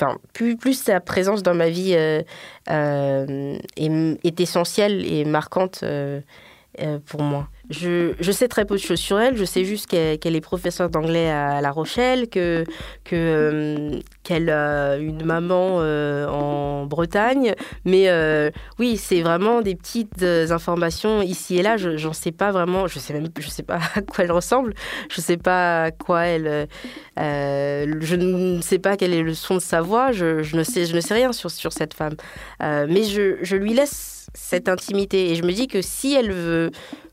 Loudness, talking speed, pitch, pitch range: -21 LUFS, 200 wpm, 175 Hz, 155-195 Hz